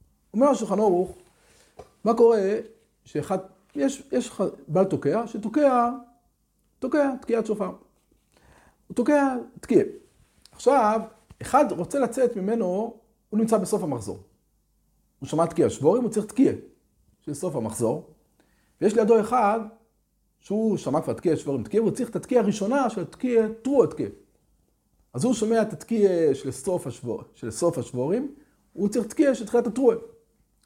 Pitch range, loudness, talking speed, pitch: 180-245 Hz, -24 LUFS, 135 wpm, 220 Hz